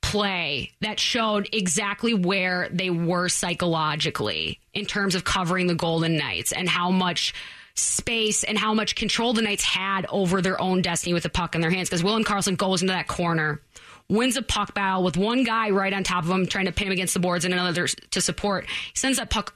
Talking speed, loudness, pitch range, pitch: 220 wpm, -23 LUFS, 175-205 Hz, 185 Hz